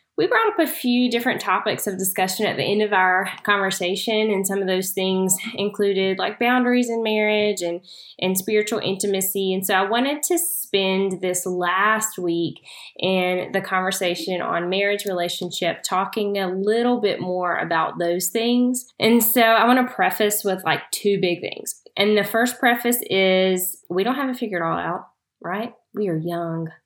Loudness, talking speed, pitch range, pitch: -21 LUFS, 175 wpm, 185-225 Hz, 195 Hz